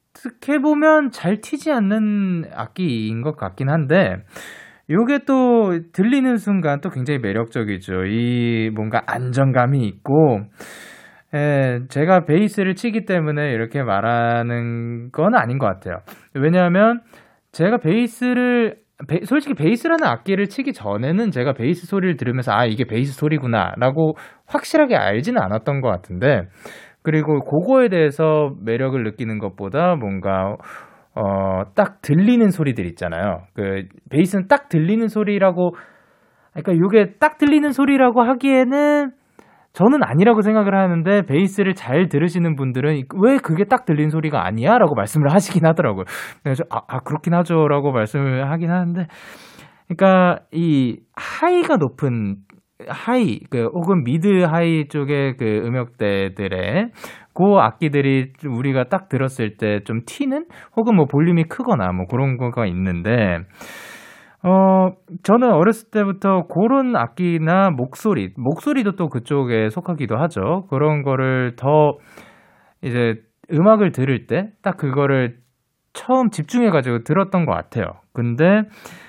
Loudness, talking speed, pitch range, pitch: -18 LUFS, 300 characters per minute, 125-200 Hz, 160 Hz